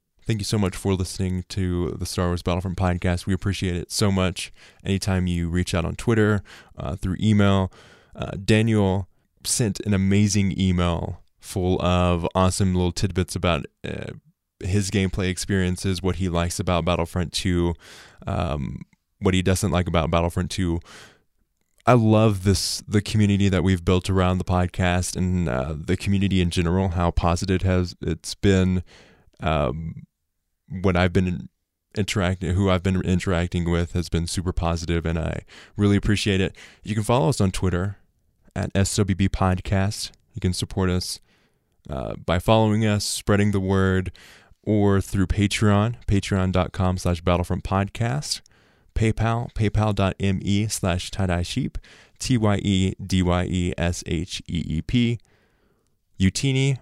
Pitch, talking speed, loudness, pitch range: 95 Hz, 150 wpm, -23 LUFS, 90-100 Hz